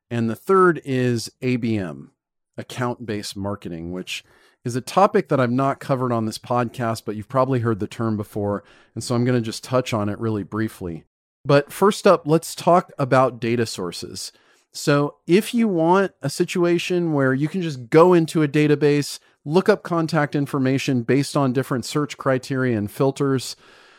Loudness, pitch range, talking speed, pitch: -21 LUFS, 115-155 Hz, 175 wpm, 130 Hz